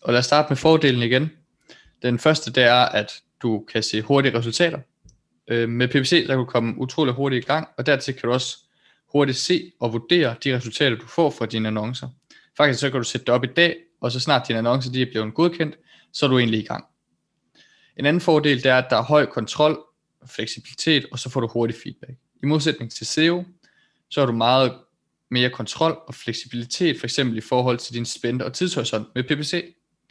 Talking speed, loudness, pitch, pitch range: 210 wpm, -21 LUFS, 130 Hz, 120-150 Hz